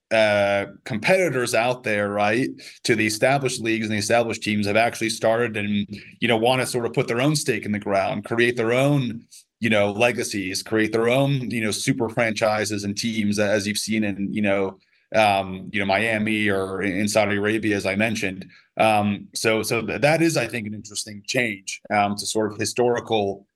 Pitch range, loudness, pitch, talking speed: 100-120 Hz, -22 LUFS, 110 Hz, 195 wpm